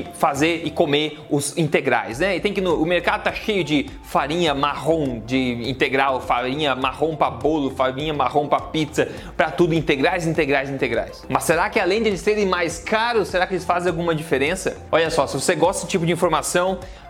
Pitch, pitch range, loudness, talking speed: 160 Hz, 145-180 Hz, -21 LUFS, 195 wpm